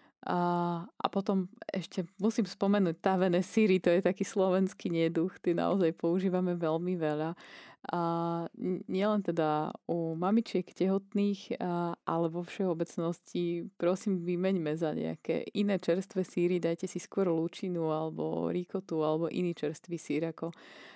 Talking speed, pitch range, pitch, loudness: 125 wpm, 170-190 Hz, 175 Hz, -32 LUFS